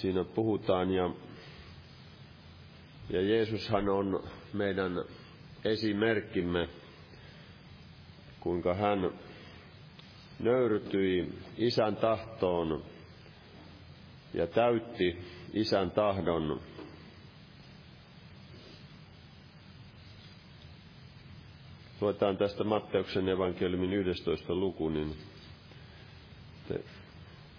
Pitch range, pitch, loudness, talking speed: 85-105 Hz, 95 Hz, -32 LUFS, 50 wpm